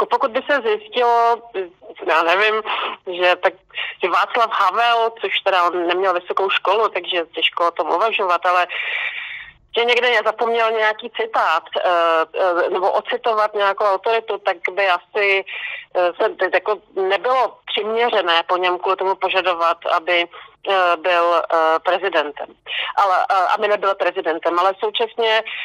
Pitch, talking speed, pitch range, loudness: 195 Hz, 125 wpm, 180-230 Hz, -18 LUFS